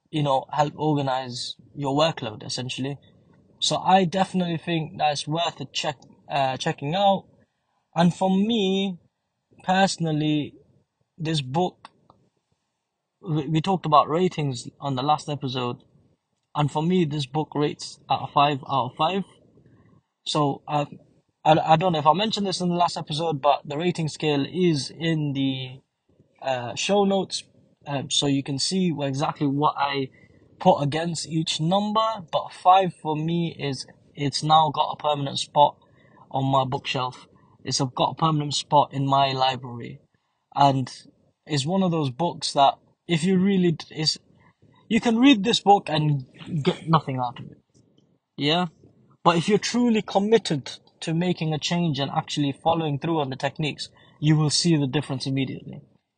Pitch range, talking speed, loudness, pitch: 140-170 Hz, 155 wpm, -24 LUFS, 150 Hz